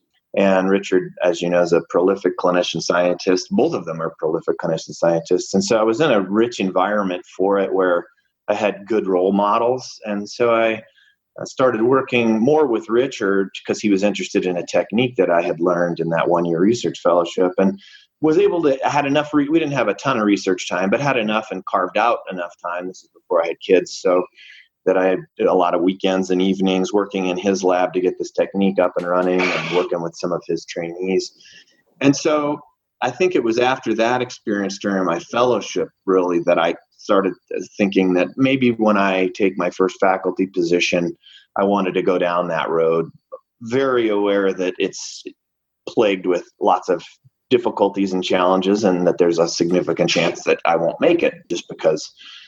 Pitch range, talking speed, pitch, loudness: 90-110 Hz, 200 wpm, 95 Hz, -19 LUFS